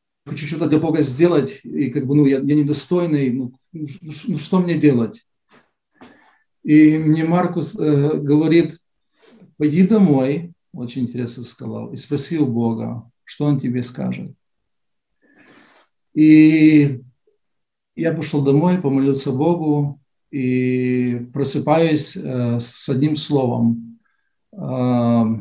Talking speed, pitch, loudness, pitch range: 120 wpm, 145 Hz, -18 LUFS, 125-155 Hz